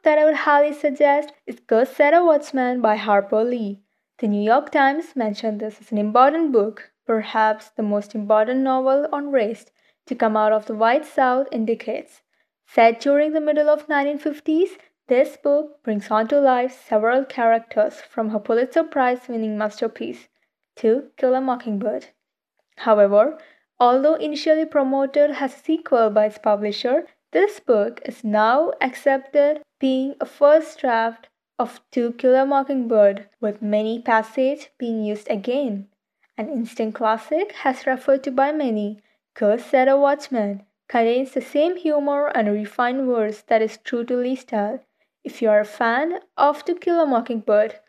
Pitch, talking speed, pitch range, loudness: 255 Hz, 160 wpm, 220-285 Hz, -20 LUFS